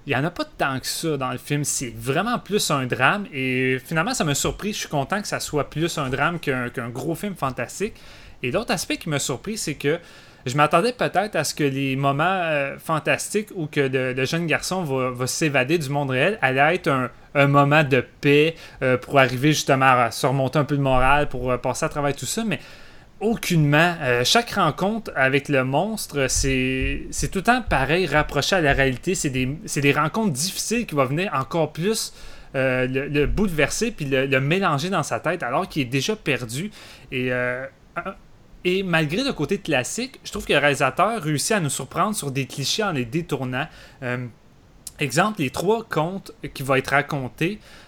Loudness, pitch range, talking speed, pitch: -22 LUFS, 135-175 Hz, 210 wpm, 145 Hz